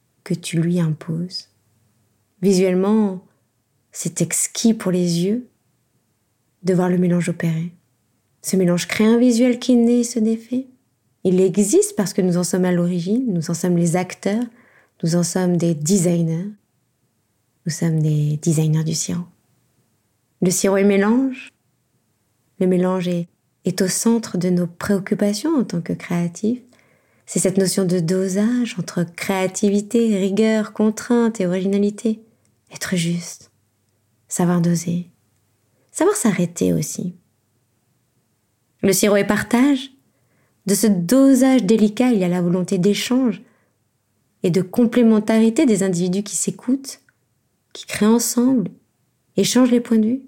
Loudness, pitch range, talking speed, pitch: -19 LUFS, 160-215 Hz, 135 wpm, 185 Hz